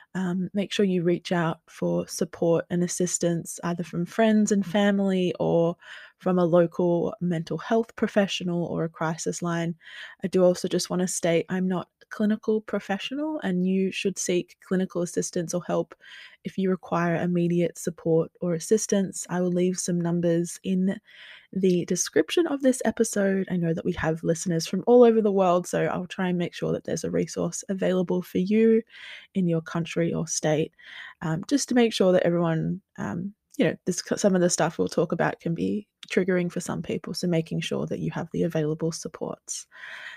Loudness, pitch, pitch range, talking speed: -26 LUFS, 180 Hz, 170-200 Hz, 185 wpm